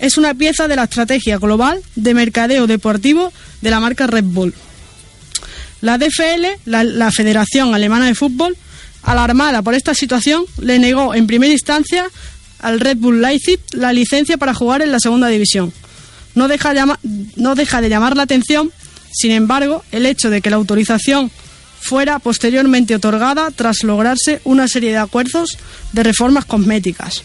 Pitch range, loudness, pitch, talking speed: 225-285 Hz, -13 LUFS, 250 Hz, 160 wpm